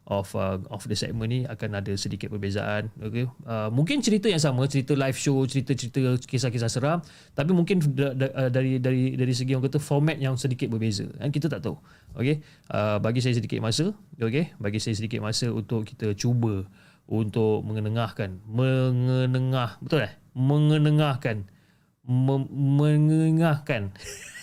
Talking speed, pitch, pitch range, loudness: 150 wpm, 130 Hz, 110-145 Hz, -26 LUFS